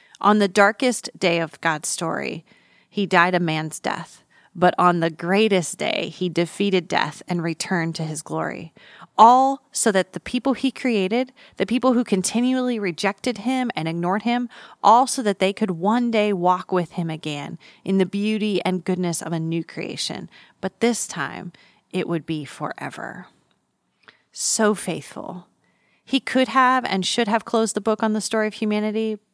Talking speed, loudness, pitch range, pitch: 170 wpm, -21 LUFS, 180-230 Hz, 200 Hz